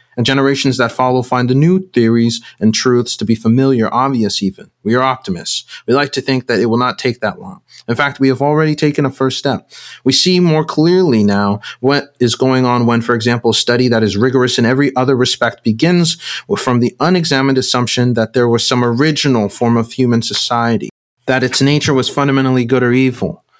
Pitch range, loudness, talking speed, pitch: 120-135 Hz, -13 LUFS, 205 wpm, 125 Hz